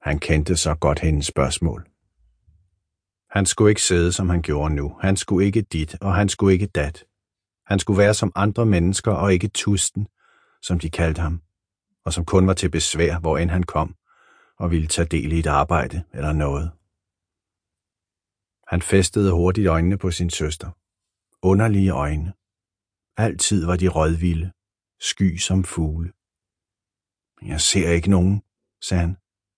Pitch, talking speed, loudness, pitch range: 90 Hz, 155 wpm, -21 LUFS, 85-95 Hz